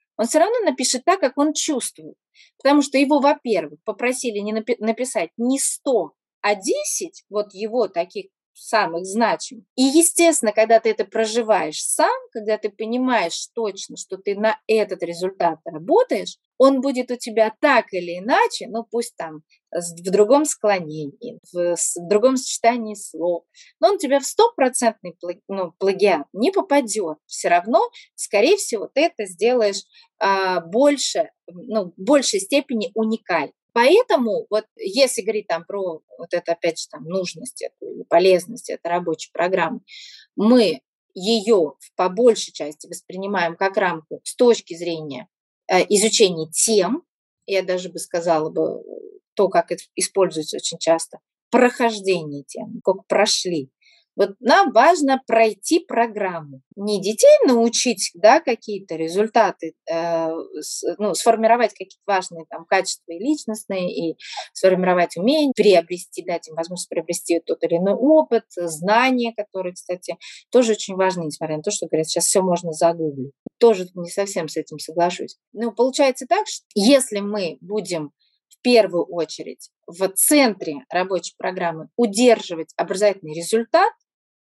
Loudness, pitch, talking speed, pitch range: -20 LUFS, 210 Hz, 140 wpm, 175-255 Hz